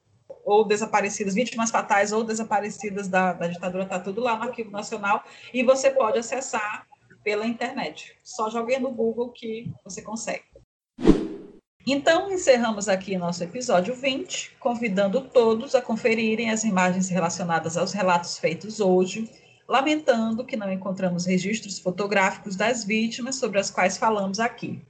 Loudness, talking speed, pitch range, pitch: -24 LUFS, 140 wpm, 195-245 Hz, 220 Hz